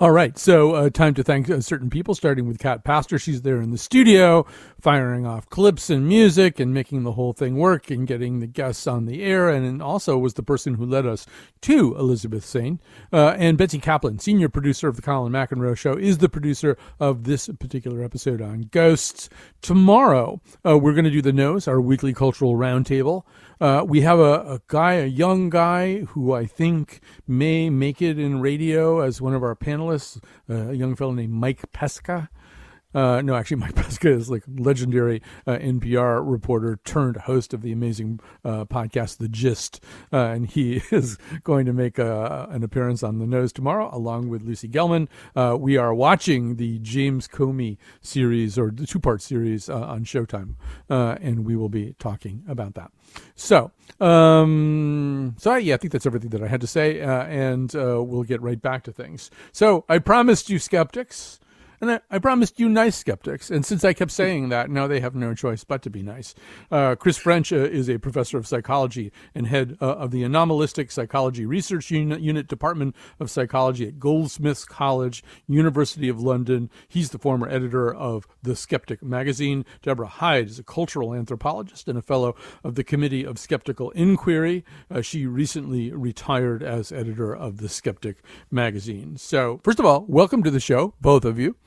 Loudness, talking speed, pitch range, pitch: -21 LUFS, 190 wpm, 120-155 Hz, 135 Hz